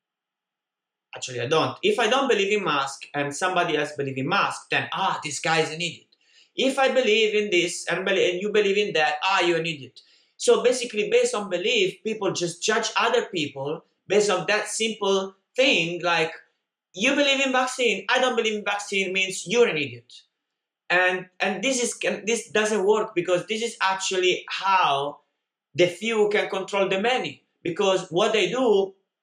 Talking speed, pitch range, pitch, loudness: 180 wpm, 175-230 Hz, 195 Hz, -23 LUFS